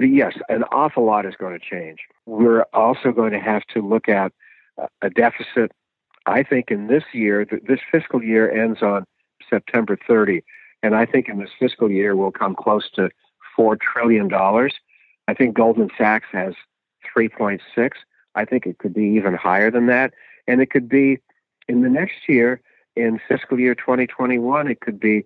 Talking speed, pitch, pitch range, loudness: 175 wpm, 115 Hz, 105-125 Hz, -19 LUFS